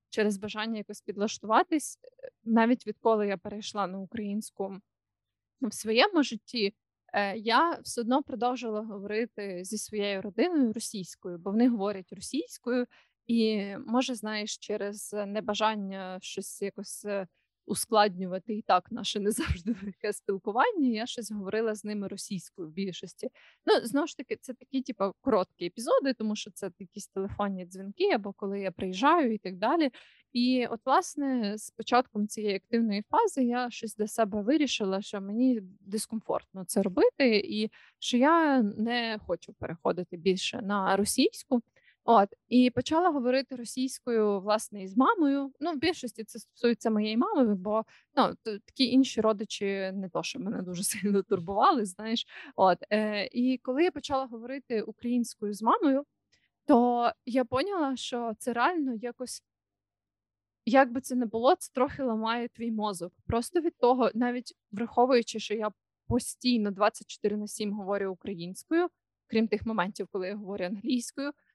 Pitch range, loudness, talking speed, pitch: 200-255 Hz, -29 LUFS, 145 wpm, 220 Hz